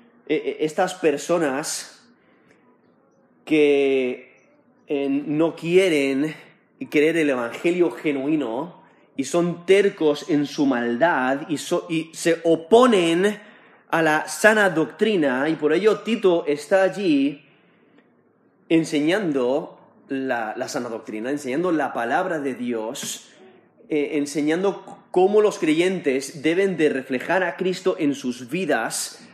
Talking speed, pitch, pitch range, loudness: 110 wpm, 160 Hz, 145-185 Hz, -21 LUFS